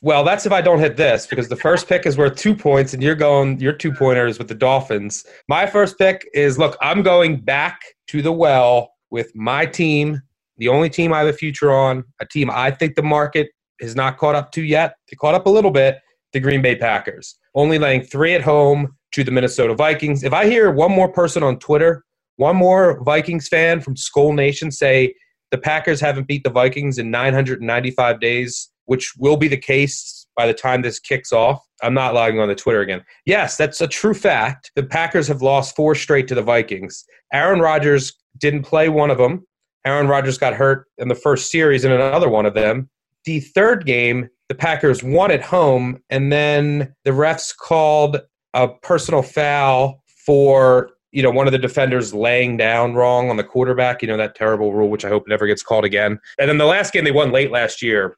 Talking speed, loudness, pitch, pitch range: 210 wpm, -16 LUFS, 140 Hz, 125-155 Hz